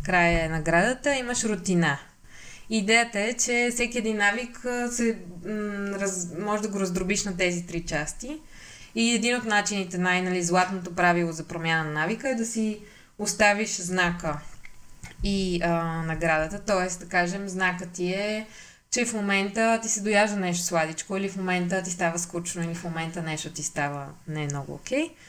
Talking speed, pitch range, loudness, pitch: 165 wpm, 170-215 Hz, -26 LUFS, 185 Hz